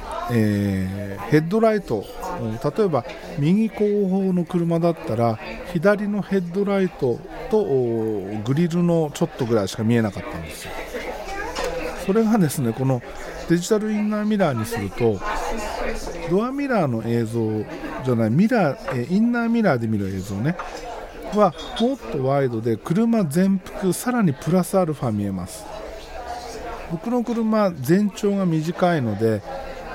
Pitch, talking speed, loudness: 170 Hz, 280 characters per minute, -22 LUFS